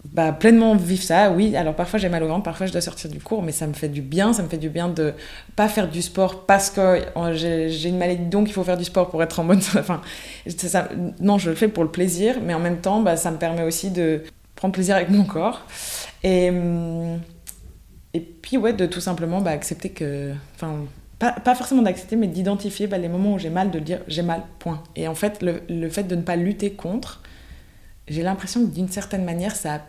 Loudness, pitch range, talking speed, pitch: -22 LUFS, 165-195 Hz, 250 wpm, 180 Hz